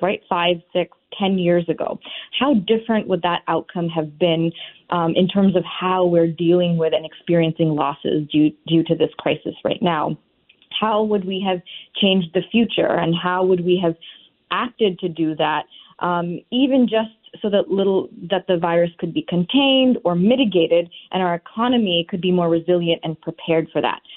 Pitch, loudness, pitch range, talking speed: 175 Hz, -20 LUFS, 165-195 Hz, 180 wpm